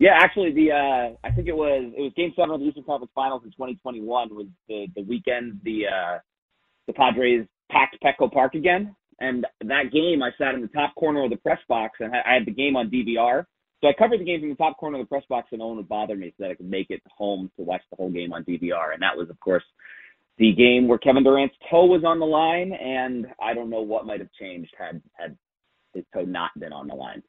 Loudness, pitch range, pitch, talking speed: -23 LUFS, 110-150 Hz, 130 Hz, 265 wpm